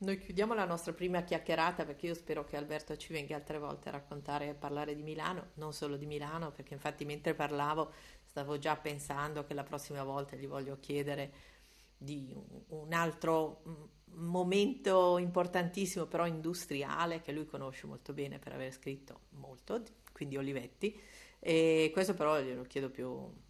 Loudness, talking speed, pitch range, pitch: -37 LUFS, 160 wpm, 145-170 Hz, 150 Hz